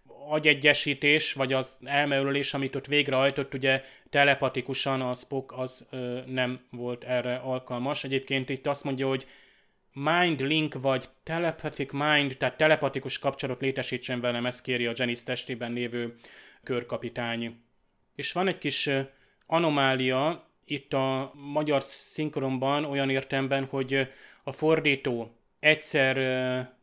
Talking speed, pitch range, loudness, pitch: 125 wpm, 130-145 Hz, -27 LUFS, 135 Hz